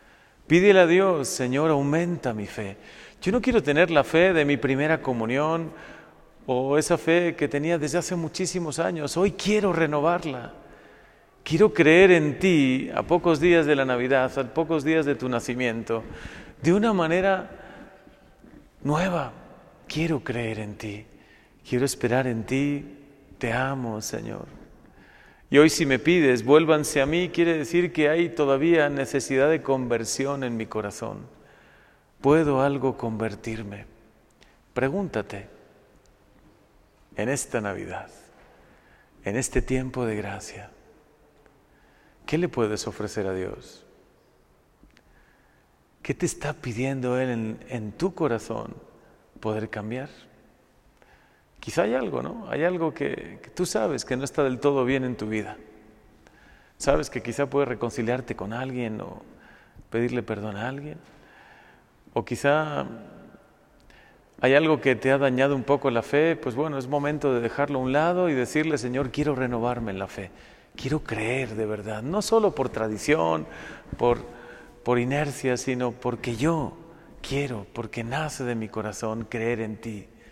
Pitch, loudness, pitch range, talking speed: 130 Hz, -24 LUFS, 115-155 Hz, 145 wpm